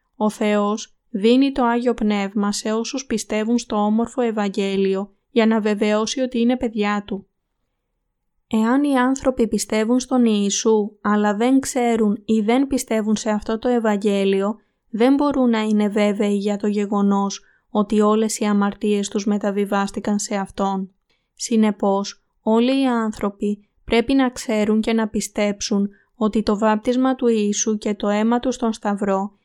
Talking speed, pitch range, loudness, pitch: 145 wpm, 205-235 Hz, -20 LUFS, 215 Hz